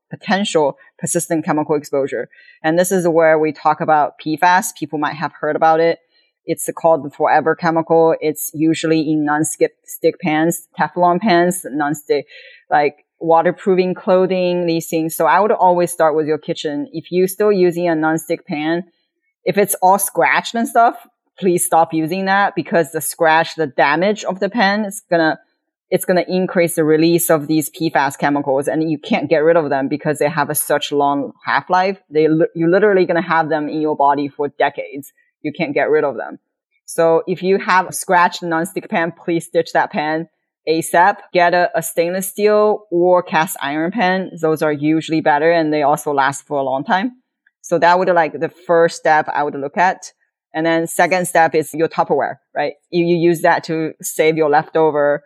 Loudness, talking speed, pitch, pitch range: -16 LUFS, 190 wpm, 165 Hz, 155-180 Hz